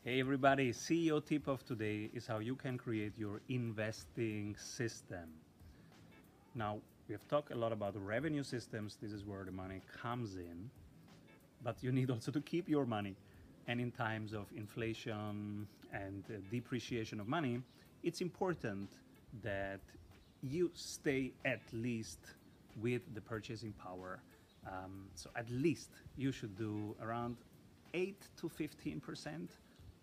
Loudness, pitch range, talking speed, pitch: -42 LUFS, 100-130 Hz, 145 wpm, 115 Hz